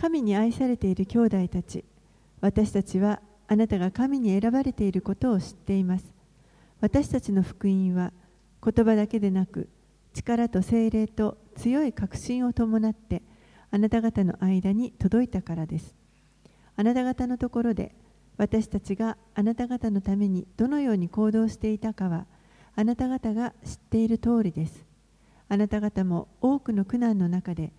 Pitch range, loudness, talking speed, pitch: 190-230 Hz, -26 LUFS, 305 characters per minute, 215 Hz